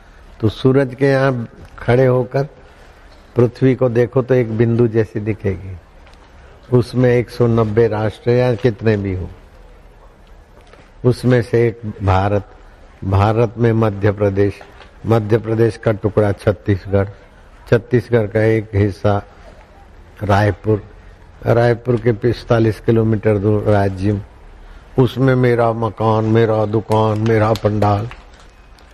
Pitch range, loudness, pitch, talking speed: 100-120 Hz, -16 LUFS, 110 Hz, 110 wpm